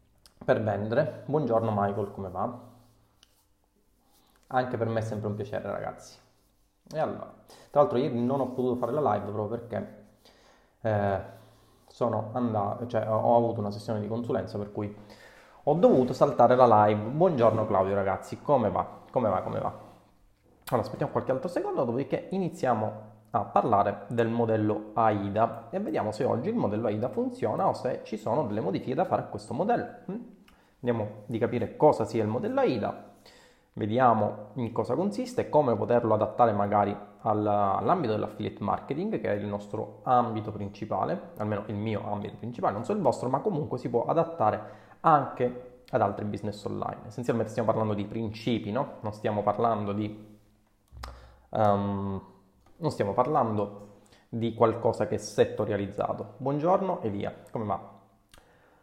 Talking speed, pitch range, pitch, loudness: 155 wpm, 105-120 Hz, 110 Hz, -28 LUFS